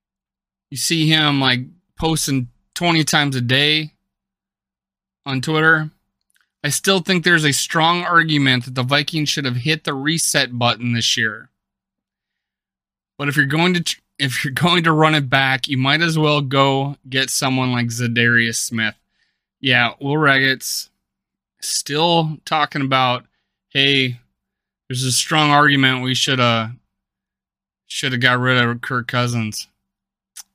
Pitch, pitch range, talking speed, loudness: 135 Hz, 125-155 Hz, 145 wpm, -17 LUFS